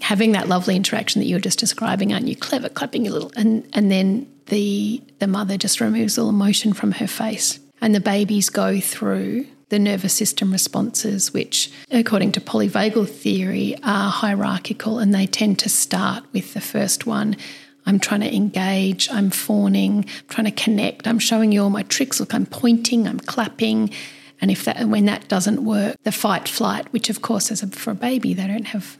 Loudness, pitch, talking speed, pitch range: -20 LUFS, 210 Hz, 200 wpm, 200-225 Hz